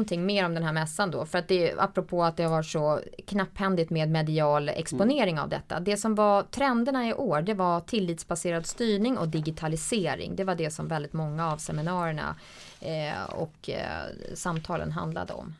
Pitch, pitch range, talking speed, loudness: 170 Hz, 160-200 Hz, 175 wpm, -28 LUFS